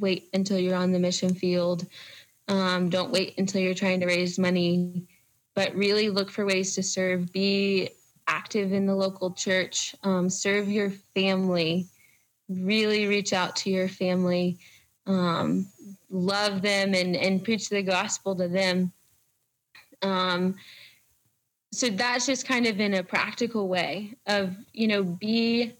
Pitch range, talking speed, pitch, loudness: 180-205 Hz, 145 wpm, 190 Hz, -26 LUFS